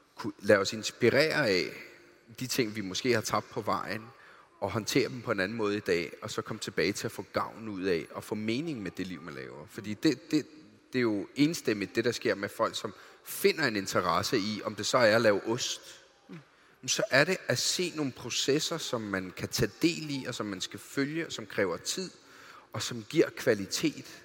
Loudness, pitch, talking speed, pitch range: -30 LUFS, 120 Hz, 220 wpm, 105-150 Hz